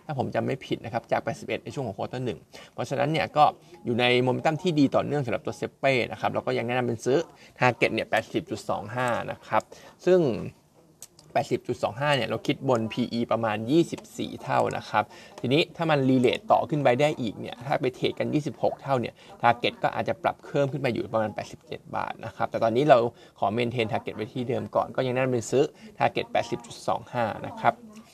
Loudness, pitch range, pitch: -27 LUFS, 115-145 Hz, 125 Hz